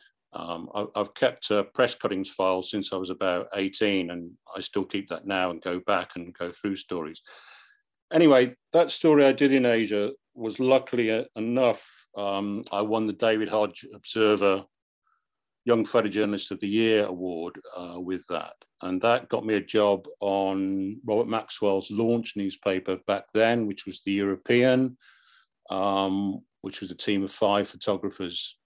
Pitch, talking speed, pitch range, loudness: 100 Hz, 160 wpm, 95-110 Hz, -26 LUFS